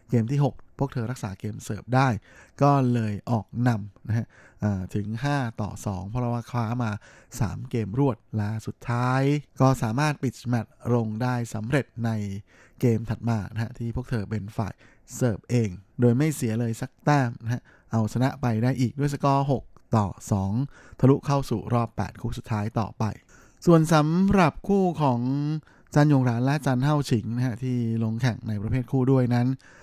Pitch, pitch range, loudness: 120 Hz, 110-135 Hz, -26 LUFS